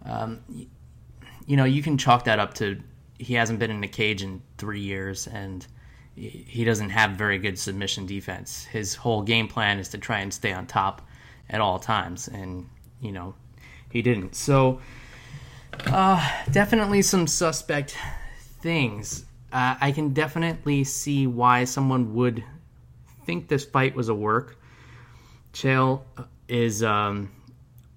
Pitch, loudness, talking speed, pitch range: 120 Hz, -24 LUFS, 145 wpm, 105-130 Hz